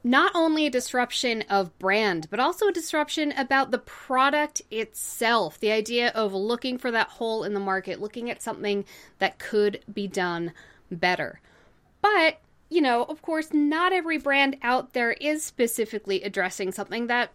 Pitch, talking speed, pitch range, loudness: 240 Hz, 165 wpm, 205-295 Hz, -25 LUFS